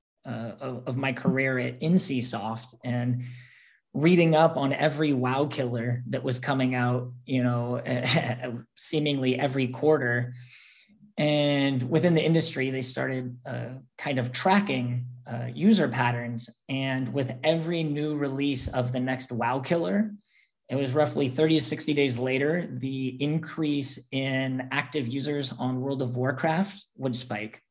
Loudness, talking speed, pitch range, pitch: -27 LUFS, 140 wpm, 125-150 Hz, 130 Hz